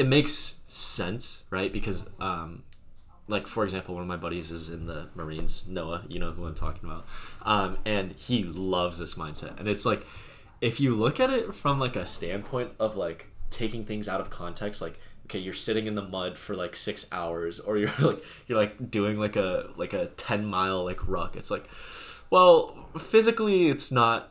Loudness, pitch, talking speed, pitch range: -28 LUFS, 105 Hz, 200 wpm, 90-115 Hz